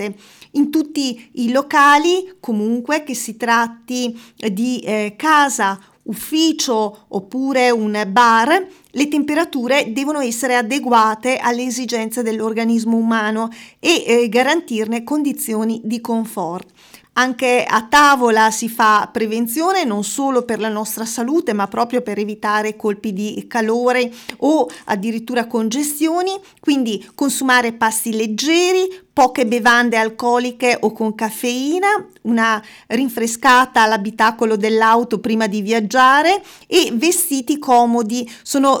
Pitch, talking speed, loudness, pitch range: 240 Hz, 115 wpm, -16 LUFS, 220-275 Hz